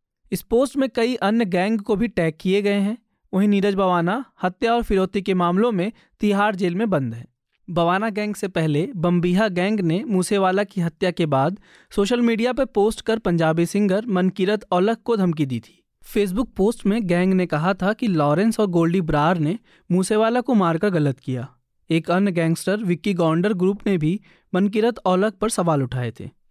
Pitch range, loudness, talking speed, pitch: 175-215 Hz, -21 LUFS, 190 wpm, 190 Hz